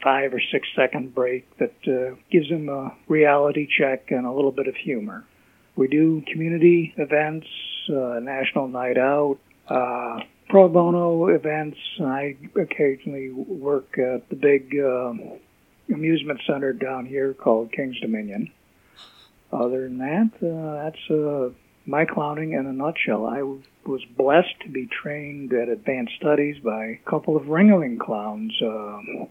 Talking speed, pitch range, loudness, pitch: 145 wpm, 130-155 Hz, -23 LUFS, 140 Hz